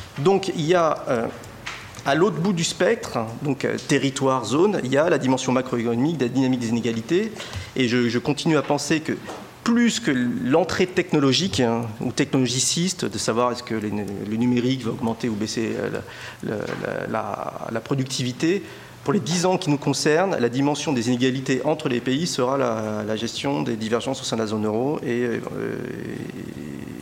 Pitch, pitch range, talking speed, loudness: 130 Hz, 120-155 Hz, 180 wpm, -23 LUFS